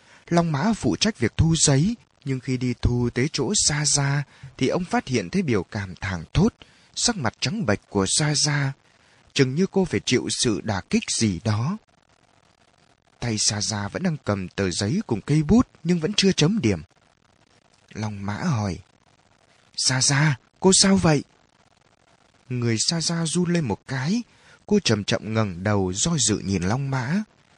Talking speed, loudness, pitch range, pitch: 180 wpm, -23 LUFS, 105-170 Hz, 135 Hz